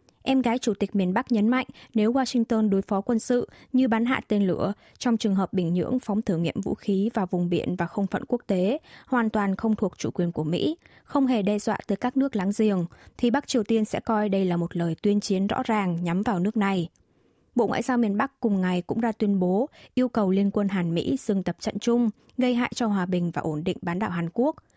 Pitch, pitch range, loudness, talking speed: 210 Hz, 190-240 Hz, -25 LUFS, 255 wpm